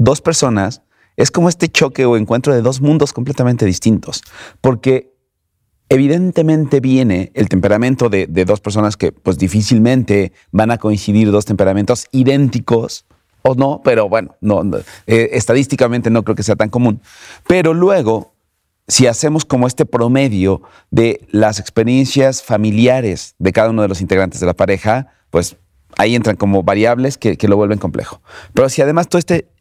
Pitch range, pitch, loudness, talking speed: 105-130 Hz, 115 Hz, -14 LUFS, 160 wpm